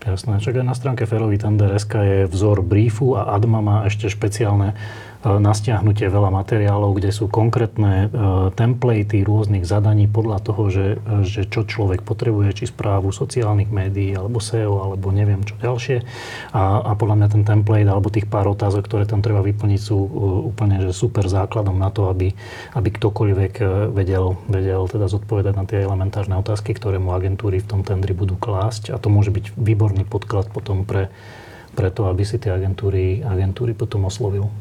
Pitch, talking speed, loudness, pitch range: 105 Hz, 170 wpm, -19 LUFS, 100-110 Hz